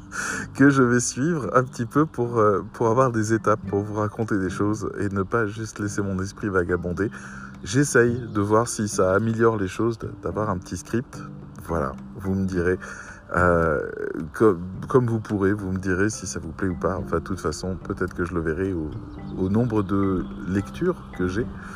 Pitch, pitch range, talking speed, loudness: 100 Hz, 95-115 Hz, 195 wpm, -24 LUFS